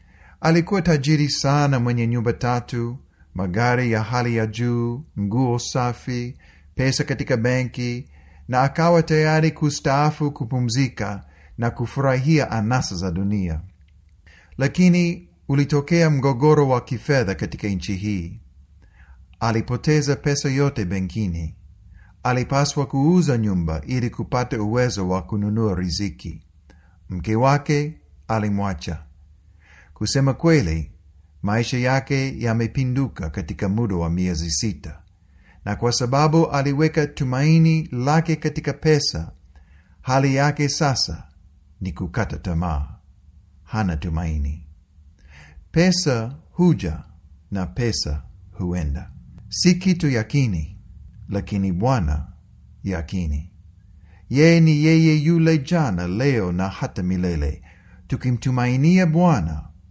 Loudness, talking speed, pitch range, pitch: -21 LUFS, 100 wpm, 85-140 Hz, 110 Hz